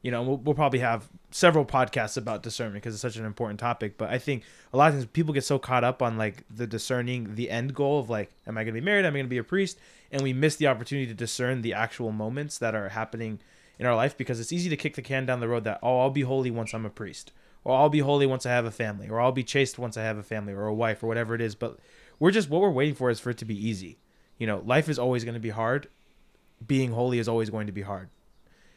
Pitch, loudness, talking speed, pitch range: 120 Hz, -27 LUFS, 290 wpm, 110-135 Hz